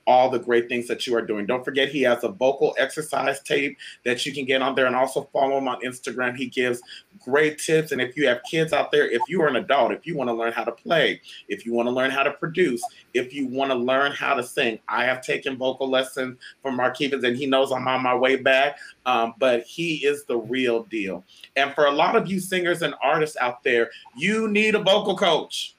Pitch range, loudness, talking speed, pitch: 125-160 Hz, -23 LUFS, 250 wpm, 135 Hz